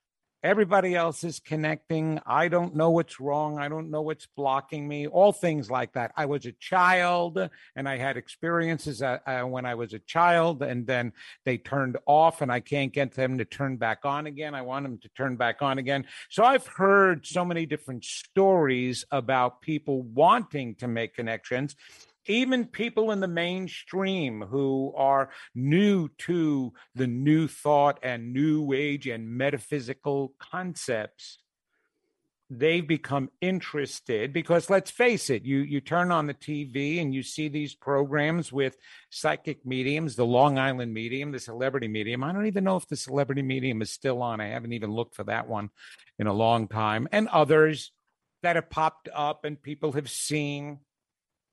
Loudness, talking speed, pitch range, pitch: -27 LUFS, 170 wpm, 130-165 Hz, 145 Hz